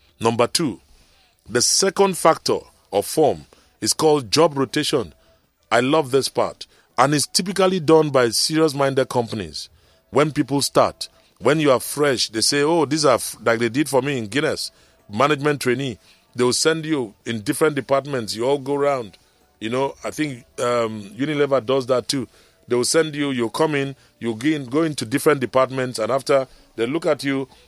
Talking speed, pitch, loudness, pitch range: 180 wpm, 135 Hz, -20 LUFS, 120-150 Hz